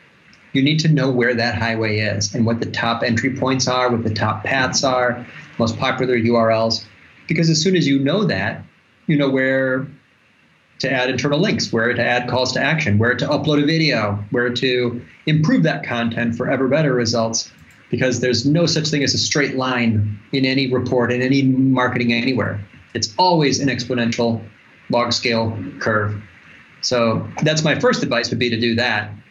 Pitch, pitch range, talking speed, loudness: 125 Hz, 115-135 Hz, 185 wpm, -18 LUFS